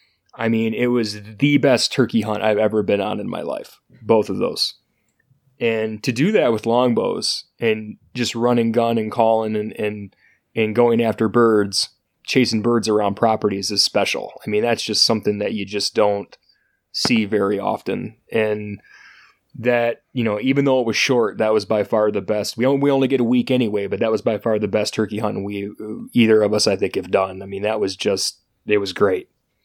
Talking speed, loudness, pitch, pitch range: 205 wpm, -19 LUFS, 110 Hz, 105-120 Hz